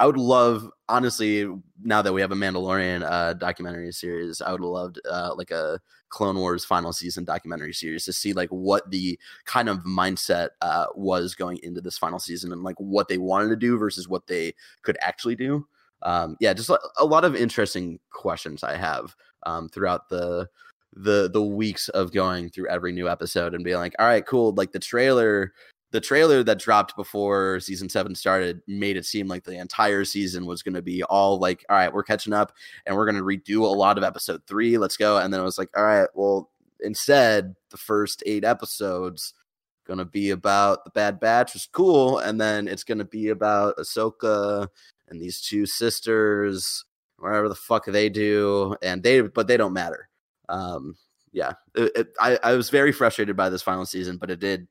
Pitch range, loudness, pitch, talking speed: 90-105 Hz, -23 LUFS, 95 Hz, 200 wpm